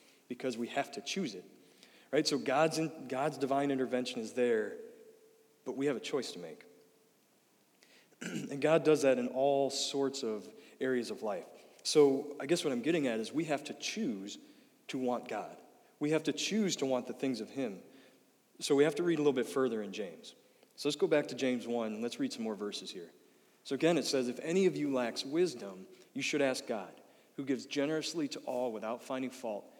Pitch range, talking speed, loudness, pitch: 130-165 Hz, 210 wpm, -34 LUFS, 140 Hz